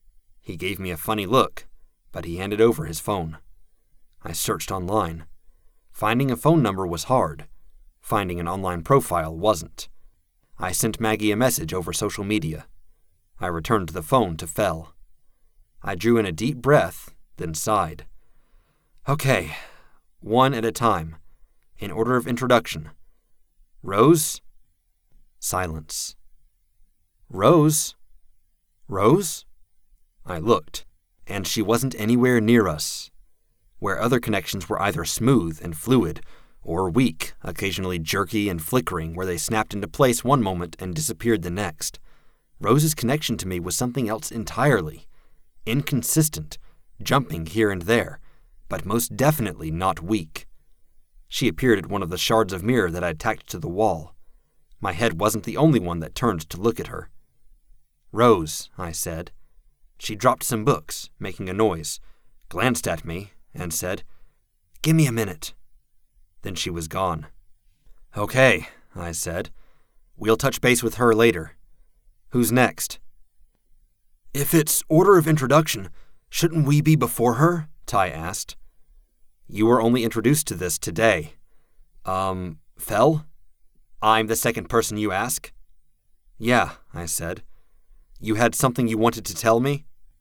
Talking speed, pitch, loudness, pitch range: 140 wpm, 100 Hz, -22 LUFS, 85-120 Hz